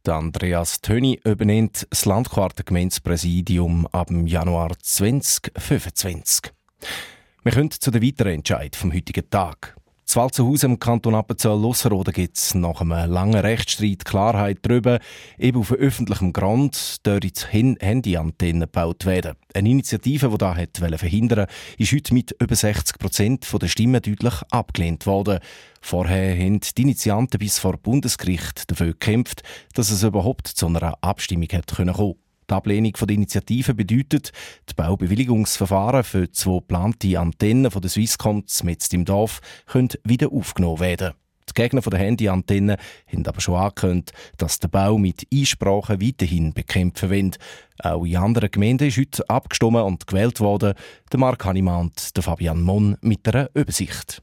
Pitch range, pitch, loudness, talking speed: 90-115 Hz, 100 Hz, -21 LUFS, 145 wpm